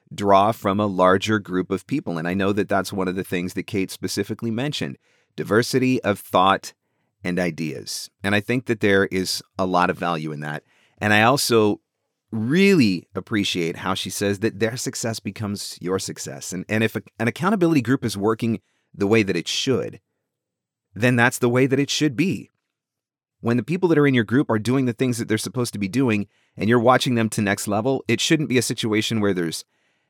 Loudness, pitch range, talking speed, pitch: -21 LUFS, 95-125 Hz, 210 wpm, 110 Hz